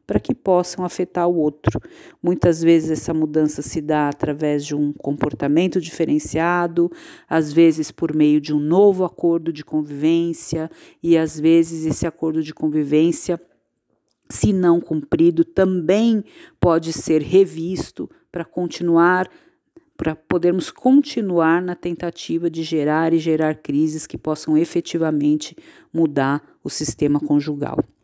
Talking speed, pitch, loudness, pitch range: 130 wpm, 165 Hz, -19 LUFS, 155-175 Hz